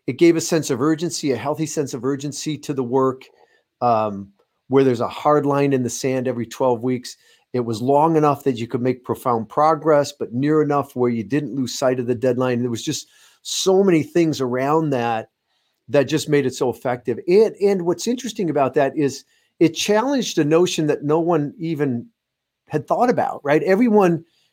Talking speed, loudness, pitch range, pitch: 200 wpm, -20 LUFS, 130-160 Hz, 145 Hz